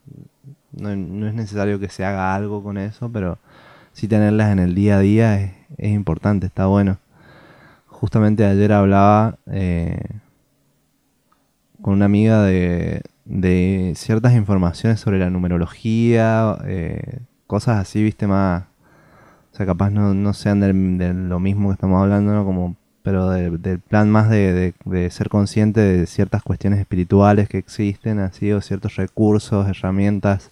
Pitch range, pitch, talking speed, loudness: 95-105 Hz, 100 Hz, 155 wpm, -18 LUFS